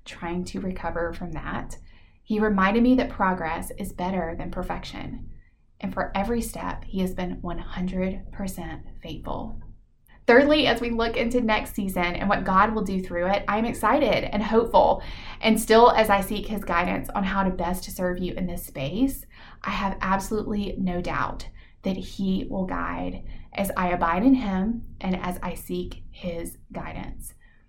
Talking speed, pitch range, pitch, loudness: 170 wpm, 170-215 Hz, 190 Hz, -25 LUFS